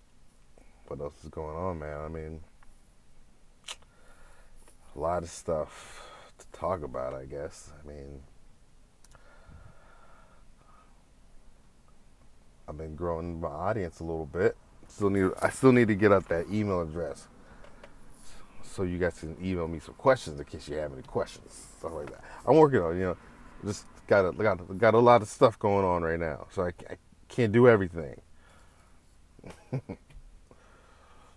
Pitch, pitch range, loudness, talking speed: 85 Hz, 75-95 Hz, -28 LUFS, 155 wpm